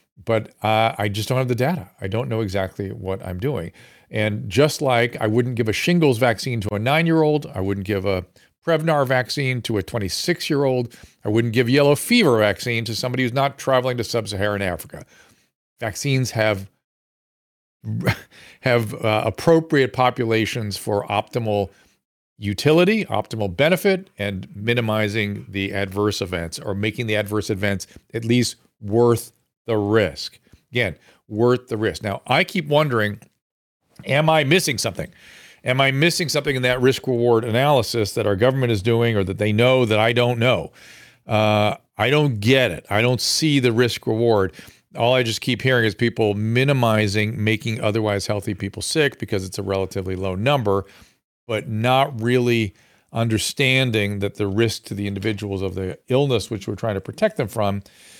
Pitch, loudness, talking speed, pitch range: 115 Hz, -20 LUFS, 170 wpm, 105-130 Hz